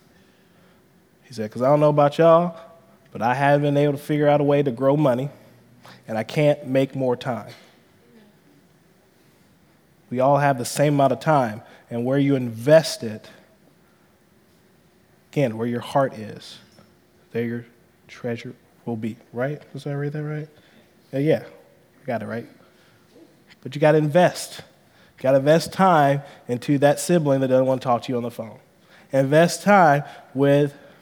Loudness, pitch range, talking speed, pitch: -21 LUFS, 125-155 Hz, 170 wpm, 140 Hz